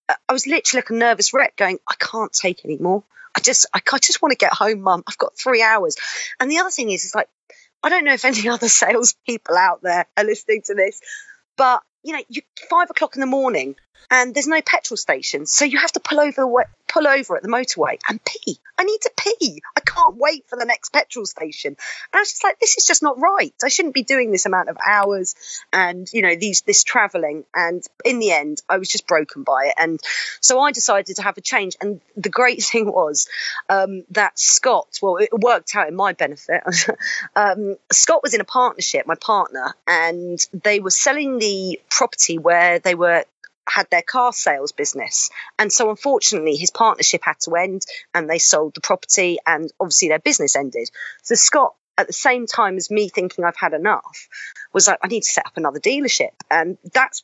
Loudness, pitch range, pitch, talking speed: -17 LUFS, 190-285 Hz, 230 Hz, 215 wpm